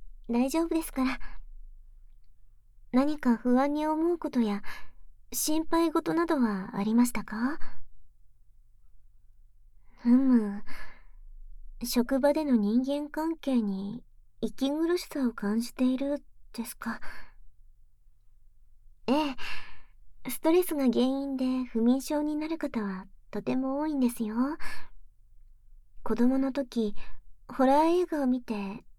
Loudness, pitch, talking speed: -29 LUFS, 240 Hz, 190 characters per minute